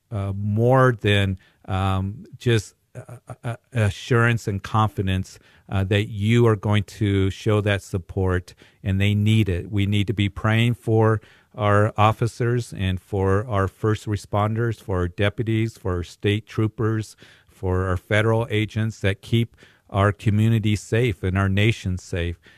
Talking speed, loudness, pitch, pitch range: 150 wpm, -22 LUFS, 105 Hz, 100-115 Hz